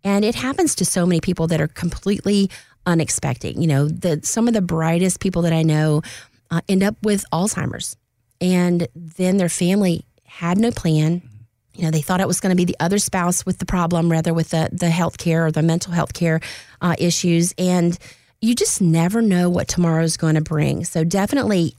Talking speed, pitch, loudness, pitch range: 205 wpm, 170 Hz, -19 LUFS, 160-185 Hz